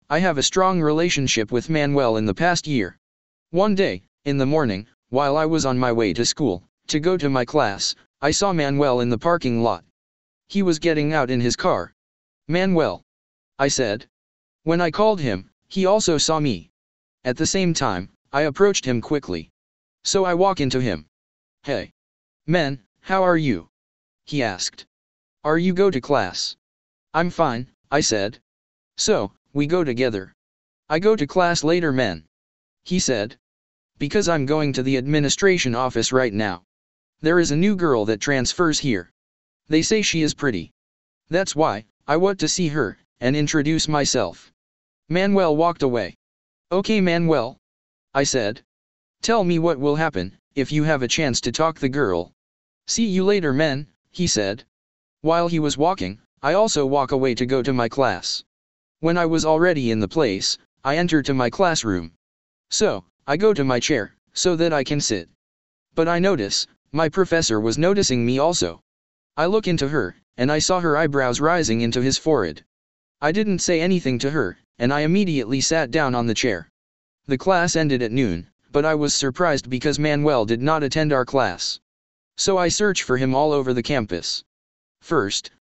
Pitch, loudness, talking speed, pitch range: 135 Hz, -21 LUFS, 175 wpm, 100-160 Hz